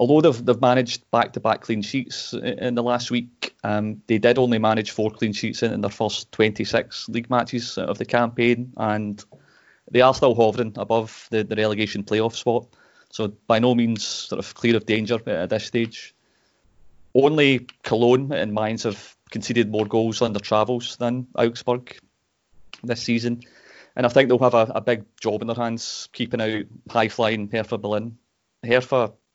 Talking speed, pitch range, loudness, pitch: 175 wpm, 110-120 Hz, -22 LUFS, 115 Hz